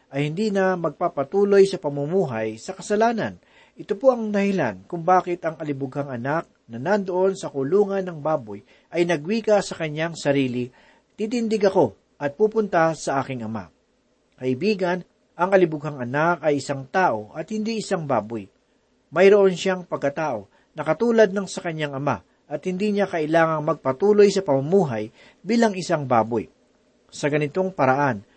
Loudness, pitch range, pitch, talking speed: -22 LUFS, 140-195 Hz, 165 Hz, 145 wpm